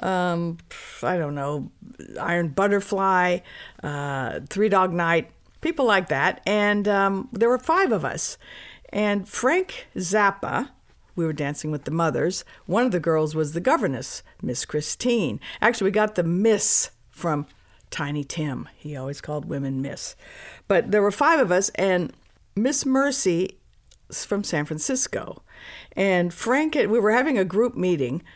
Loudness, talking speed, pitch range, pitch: -23 LUFS, 150 wpm, 155-215 Hz, 185 Hz